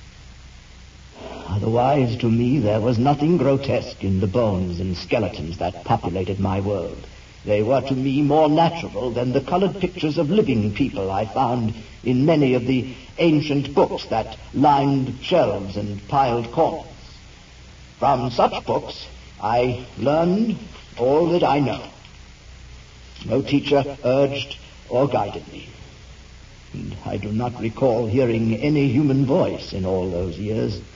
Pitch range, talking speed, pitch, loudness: 100-140 Hz, 140 wpm, 120 Hz, -21 LUFS